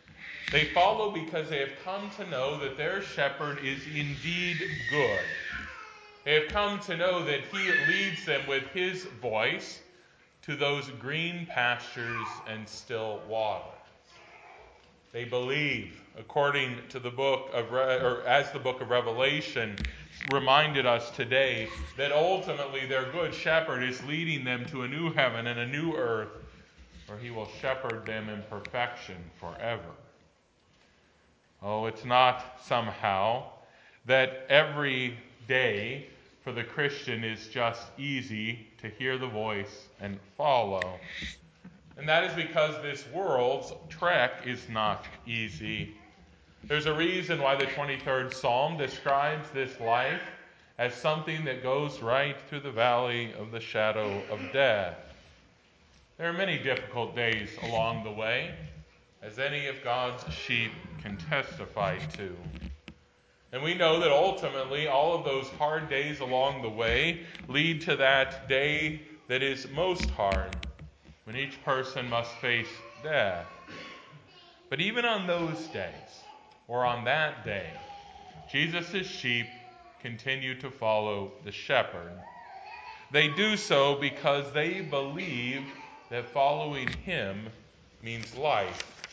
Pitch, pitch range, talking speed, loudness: 130 Hz, 115-150 Hz, 130 wpm, -30 LUFS